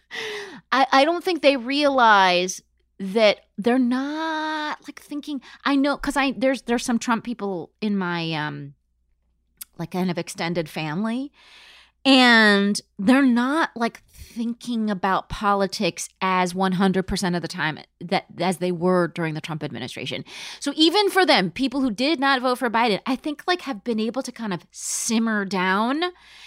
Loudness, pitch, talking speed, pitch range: -22 LUFS, 230 Hz, 160 wpm, 185-275 Hz